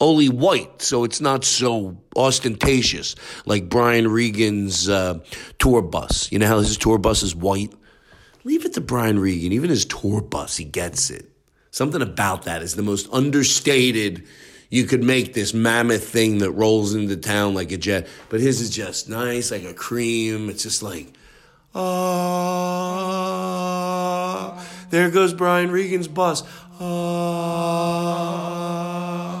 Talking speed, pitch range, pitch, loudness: 145 wpm, 105-175 Hz, 120 Hz, -20 LUFS